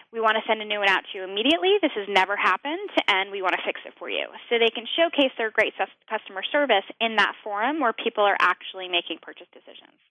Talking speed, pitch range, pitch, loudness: 250 wpm, 190-240 Hz, 215 Hz, -23 LUFS